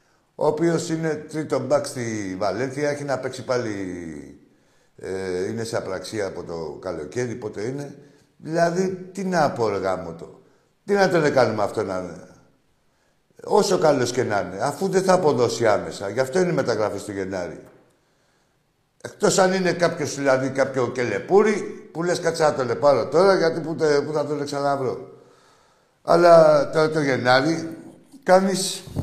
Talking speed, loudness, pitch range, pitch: 150 wpm, -22 LUFS, 125-175 Hz, 145 Hz